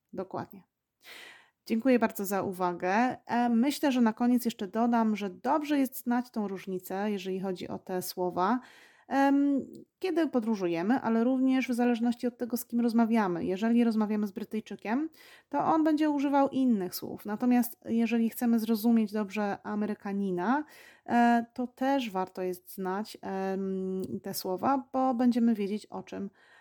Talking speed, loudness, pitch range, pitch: 140 wpm, -29 LUFS, 195-250 Hz, 230 Hz